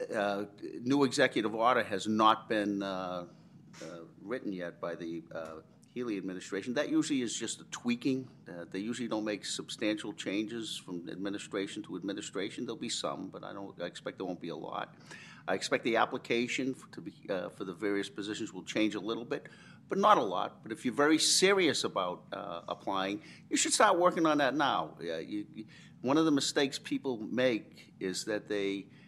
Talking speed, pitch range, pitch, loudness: 200 wpm, 100-145 Hz, 115 Hz, -33 LUFS